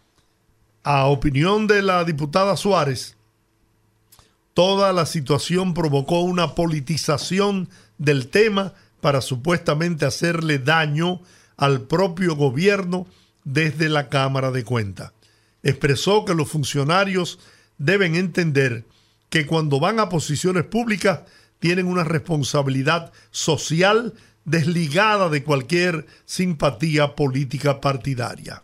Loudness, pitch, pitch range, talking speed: -20 LUFS, 155 Hz, 135-180 Hz, 100 wpm